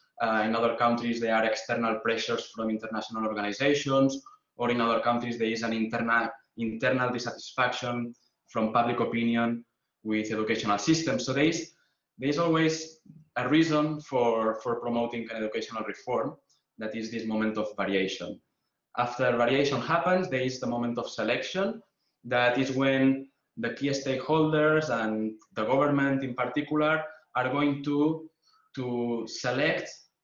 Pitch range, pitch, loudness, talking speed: 115-145 Hz, 120 Hz, -28 LUFS, 145 wpm